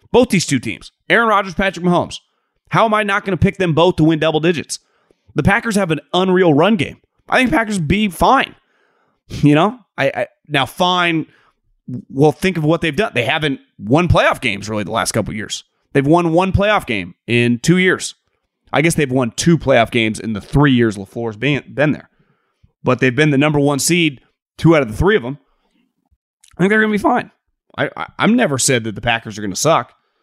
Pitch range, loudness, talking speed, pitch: 125-180 Hz, -16 LUFS, 220 wpm, 155 Hz